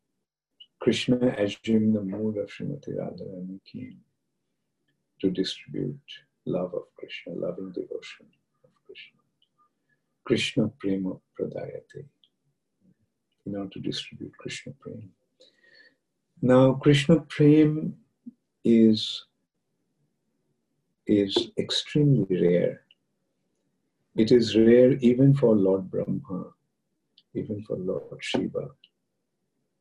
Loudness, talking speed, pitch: -24 LUFS, 90 wpm, 125 Hz